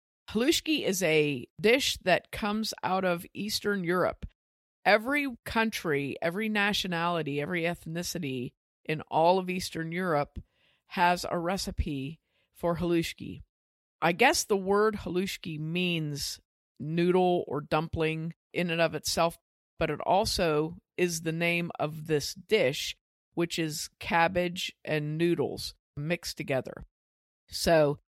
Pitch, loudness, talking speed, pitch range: 170 Hz, -29 LUFS, 120 wpm, 155-185 Hz